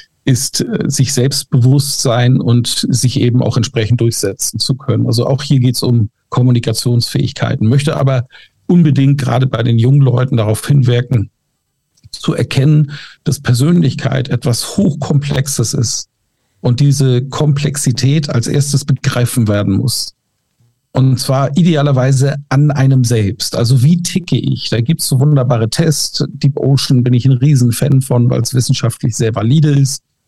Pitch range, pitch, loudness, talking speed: 120-140 Hz, 130 Hz, -13 LUFS, 145 wpm